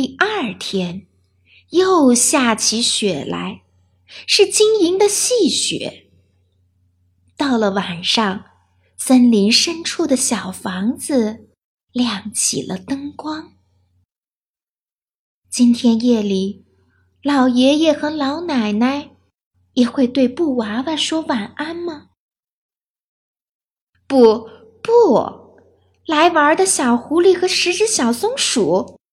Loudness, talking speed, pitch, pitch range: -16 LUFS, 135 characters per minute, 245 Hz, 190-310 Hz